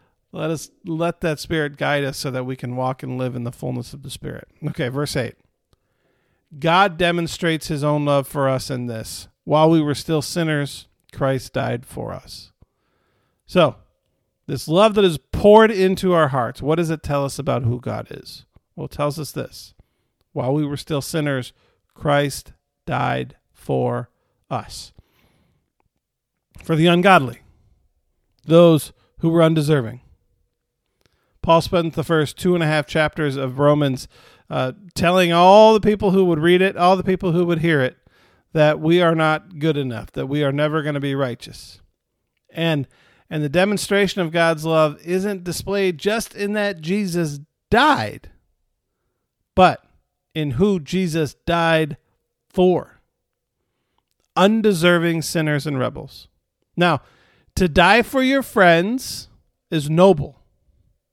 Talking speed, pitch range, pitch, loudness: 150 wpm, 130-175 Hz, 155 Hz, -19 LUFS